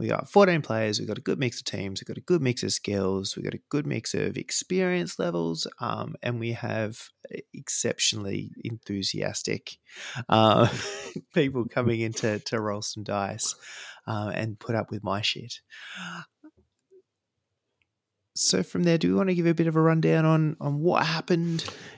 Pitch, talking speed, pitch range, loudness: 115 Hz, 175 wpm, 105-160 Hz, -26 LUFS